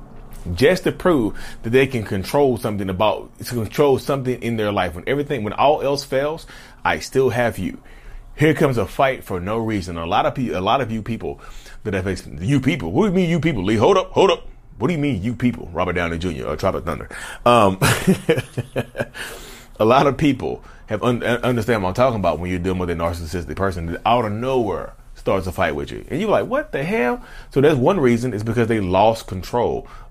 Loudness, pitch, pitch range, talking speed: -20 LUFS, 120 Hz, 95-135 Hz, 225 wpm